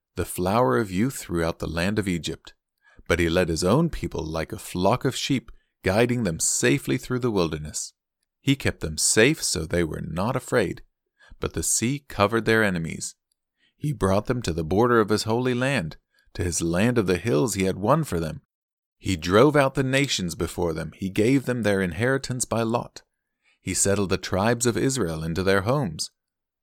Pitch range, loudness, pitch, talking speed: 85-125 Hz, -24 LUFS, 100 Hz, 190 wpm